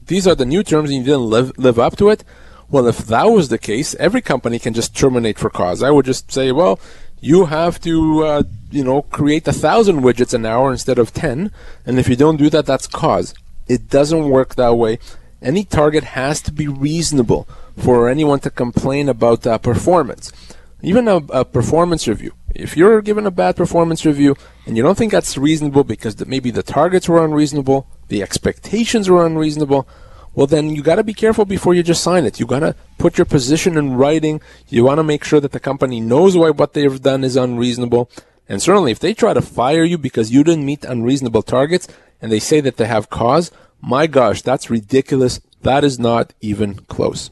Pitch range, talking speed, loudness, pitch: 125-160 Hz, 205 wpm, -15 LUFS, 140 Hz